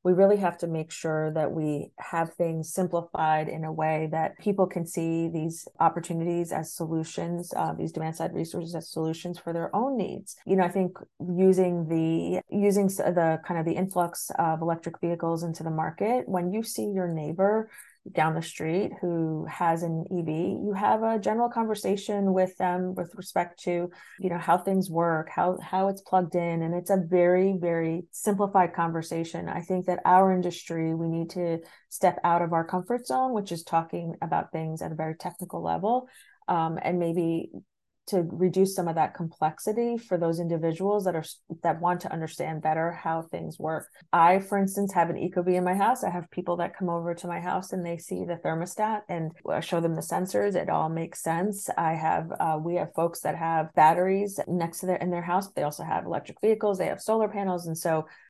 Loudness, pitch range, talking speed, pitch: -28 LUFS, 165-185 Hz, 200 wpm, 175 Hz